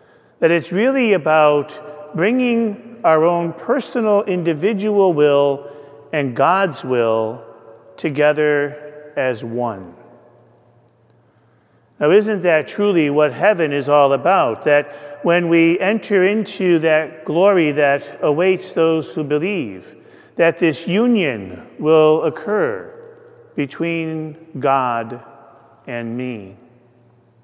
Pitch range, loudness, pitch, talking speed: 130-185 Hz, -17 LUFS, 155 Hz, 100 wpm